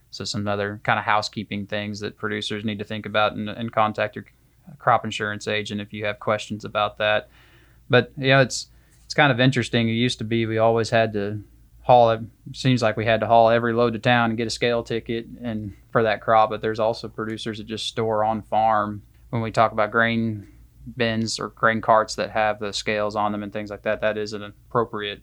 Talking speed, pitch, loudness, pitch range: 225 wpm, 110 Hz, -22 LUFS, 105-115 Hz